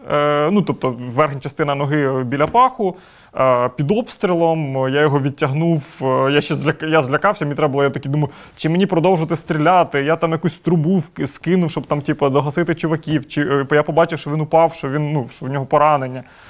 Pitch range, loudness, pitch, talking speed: 140-165 Hz, -18 LUFS, 150 Hz, 175 wpm